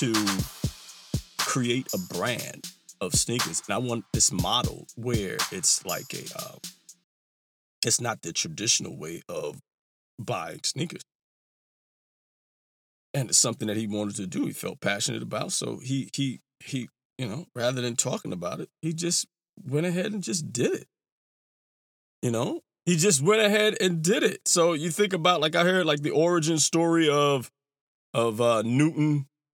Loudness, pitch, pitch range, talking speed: -26 LUFS, 155 Hz, 130-175 Hz, 150 wpm